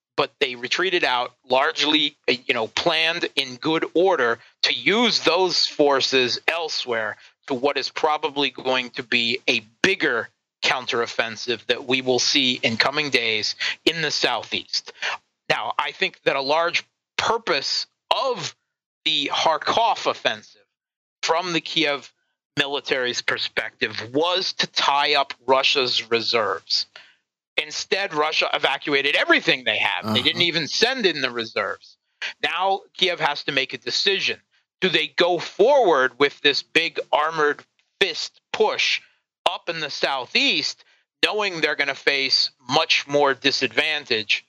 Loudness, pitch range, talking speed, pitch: -21 LUFS, 135-165 Hz, 135 wpm, 145 Hz